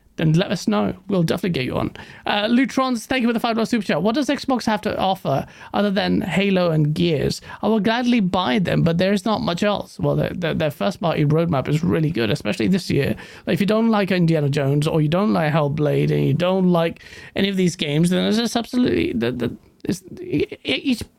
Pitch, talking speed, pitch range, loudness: 190 Hz, 230 wpm, 160-215 Hz, -20 LUFS